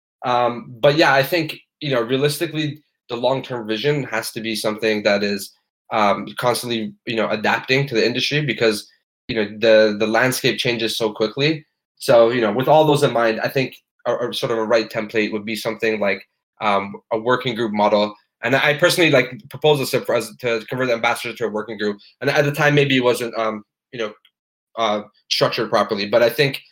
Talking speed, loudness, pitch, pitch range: 200 wpm, -19 LUFS, 120 Hz, 110-135 Hz